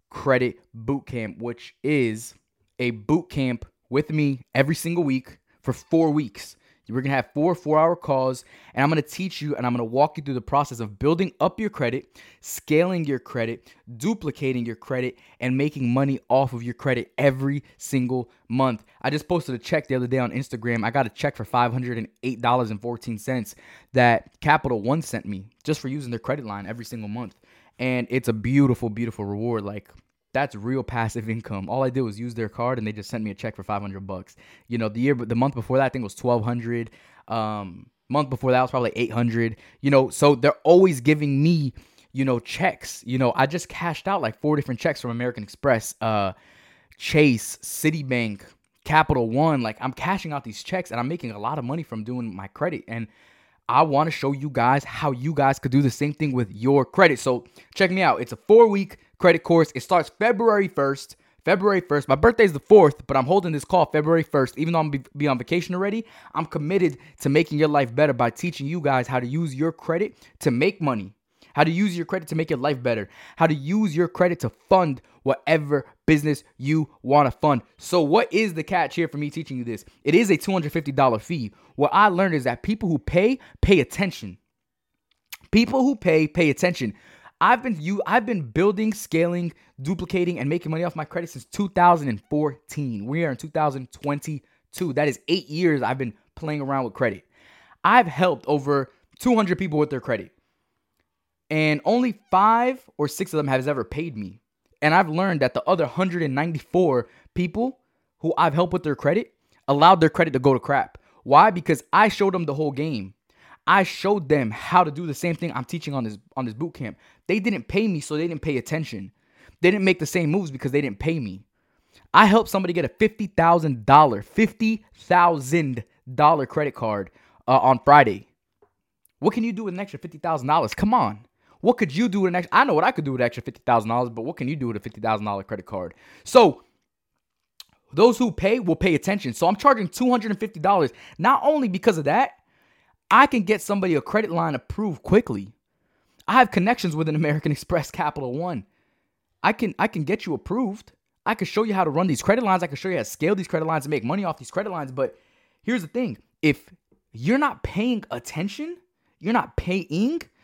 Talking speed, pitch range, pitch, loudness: 210 wpm, 125-175 Hz, 145 Hz, -22 LUFS